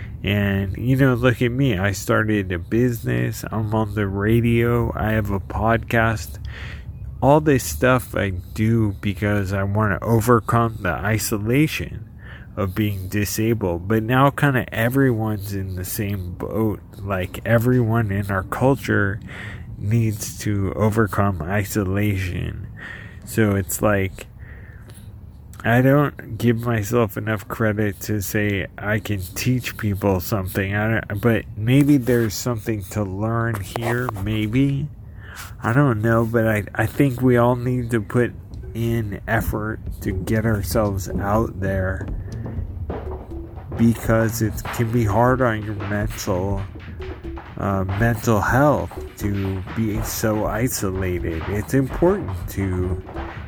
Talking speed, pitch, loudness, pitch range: 130 wpm, 105 Hz, -21 LUFS, 100-115 Hz